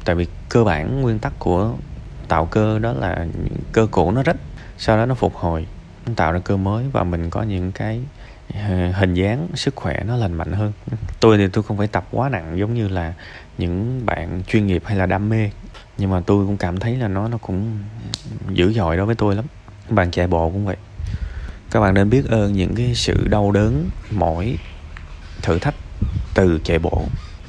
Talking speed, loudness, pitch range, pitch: 205 wpm, -20 LUFS, 90-110 Hz, 100 Hz